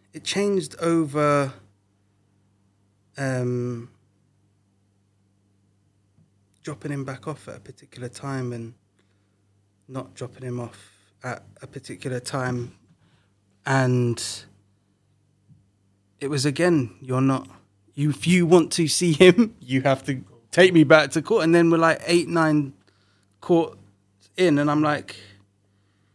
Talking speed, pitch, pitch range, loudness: 120 wpm, 125 Hz, 100-145 Hz, -21 LUFS